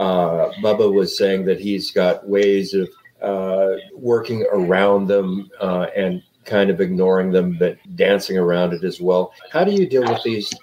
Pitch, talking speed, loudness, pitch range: 95 Hz, 175 wpm, -19 LUFS, 95-100 Hz